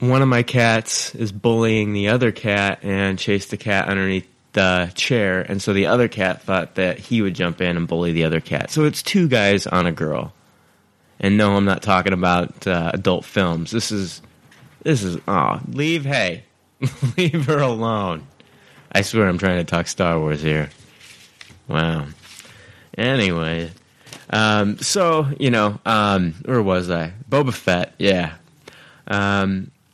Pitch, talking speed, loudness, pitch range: 100 Hz, 160 wpm, -19 LUFS, 90-115 Hz